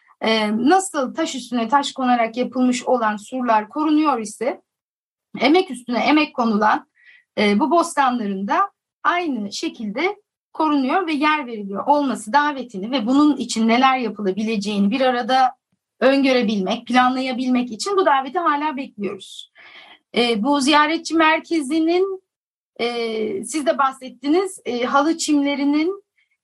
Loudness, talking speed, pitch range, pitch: -19 LUFS, 105 wpm, 230-305 Hz, 265 Hz